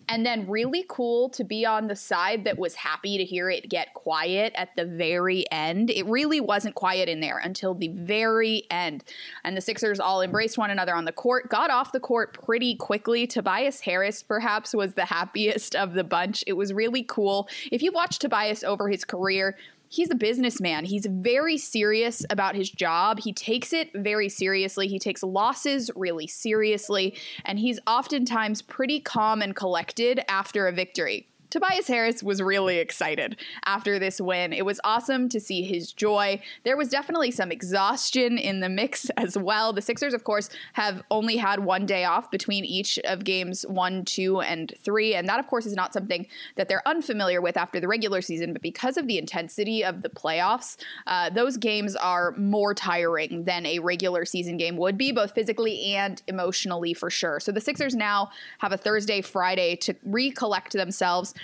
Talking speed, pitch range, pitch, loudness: 190 wpm, 185-230 Hz, 205 Hz, -26 LUFS